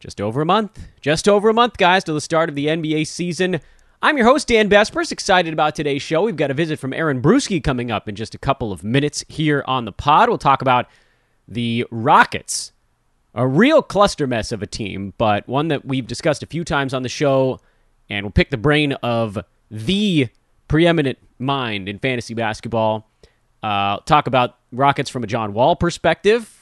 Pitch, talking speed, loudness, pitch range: 140 Hz, 200 wpm, -18 LUFS, 120-165 Hz